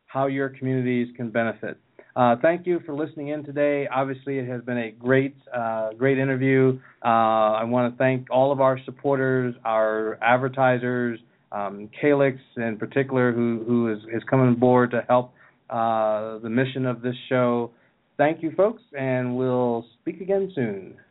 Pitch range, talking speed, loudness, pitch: 115-135 Hz, 160 wpm, -23 LUFS, 125 Hz